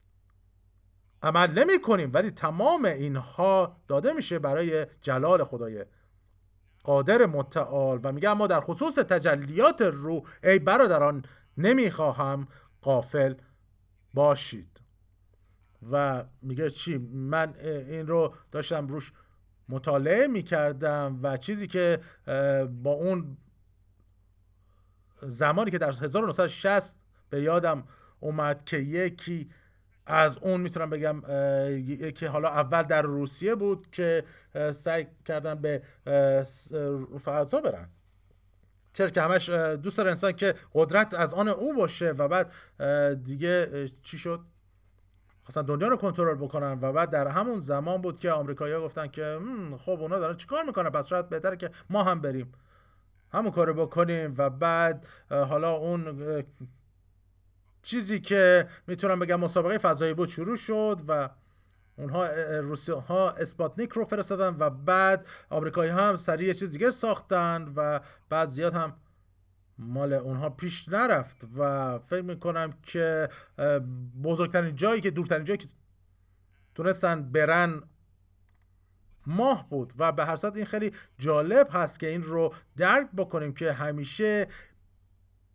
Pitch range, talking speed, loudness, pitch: 130-180 Hz, 125 wpm, -27 LUFS, 155 Hz